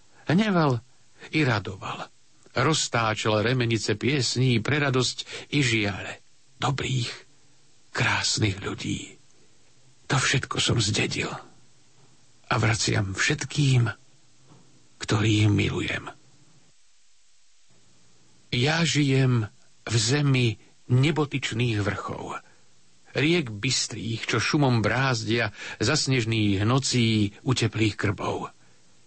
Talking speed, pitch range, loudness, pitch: 80 wpm, 110-135 Hz, -25 LUFS, 120 Hz